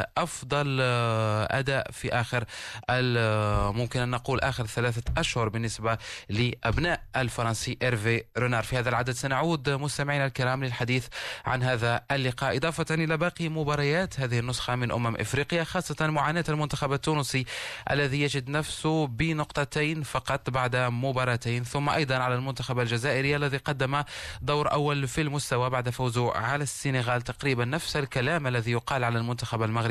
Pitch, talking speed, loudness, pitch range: 130 Hz, 135 wpm, -28 LUFS, 120-145 Hz